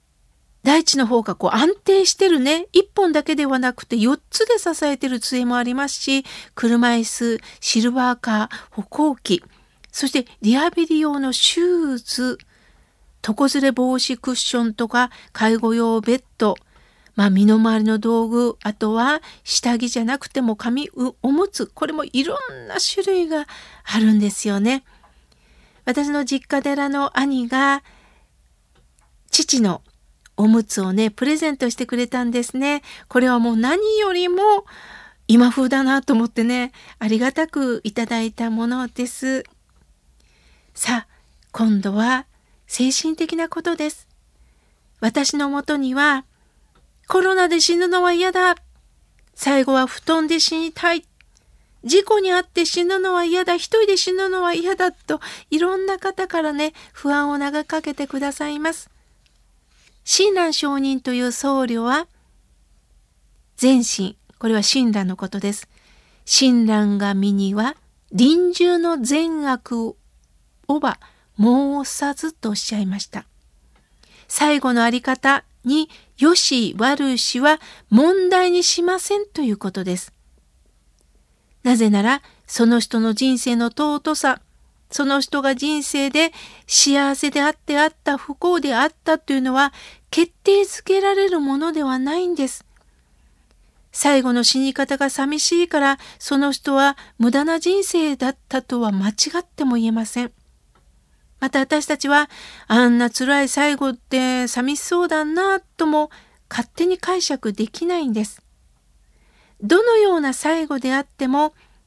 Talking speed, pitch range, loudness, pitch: 255 characters per minute, 230-310 Hz, -19 LUFS, 270 Hz